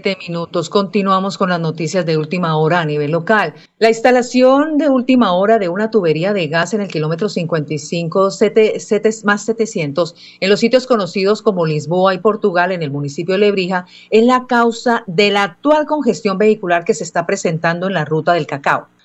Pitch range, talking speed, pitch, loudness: 170-220 Hz, 185 wpm, 195 Hz, -15 LUFS